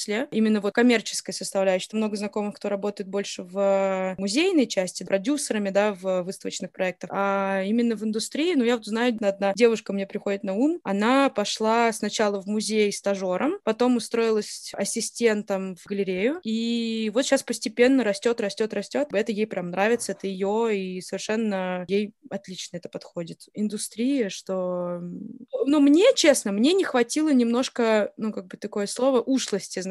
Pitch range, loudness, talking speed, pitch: 195-240 Hz, -24 LUFS, 155 wpm, 210 Hz